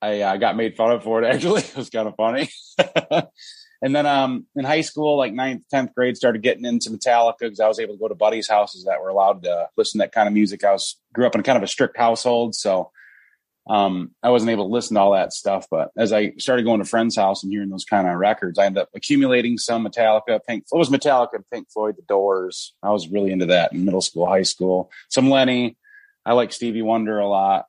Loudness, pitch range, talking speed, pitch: -20 LUFS, 100-125 Hz, 245 wpm, 115 Hz